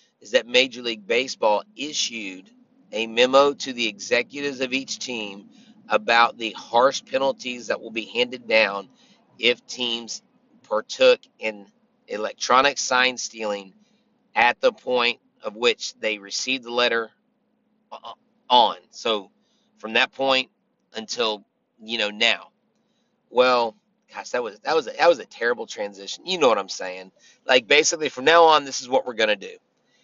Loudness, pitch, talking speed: -22 LUFS, 125 Hz, 150 wpm